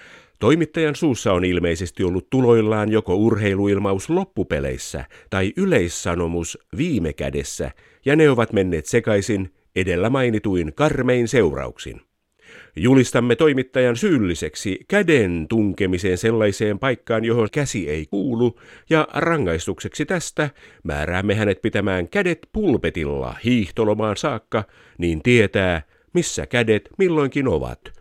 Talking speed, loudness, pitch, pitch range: 105 wpm, -20 LUFS, 110 Hz, 95-130 Hz